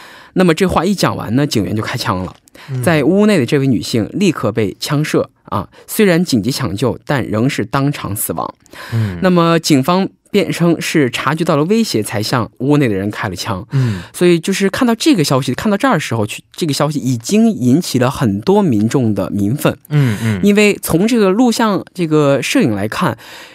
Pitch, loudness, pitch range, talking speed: 145 Hz, -14 LUFS, 120-185 Hz, 285 characters per minute